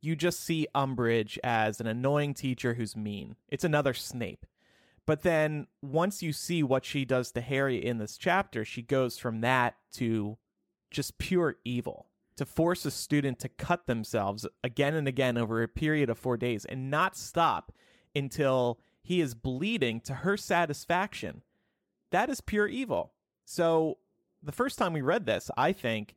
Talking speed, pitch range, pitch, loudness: 165 wpm, 120-160 Hz, 135 Hz, -30 LUFS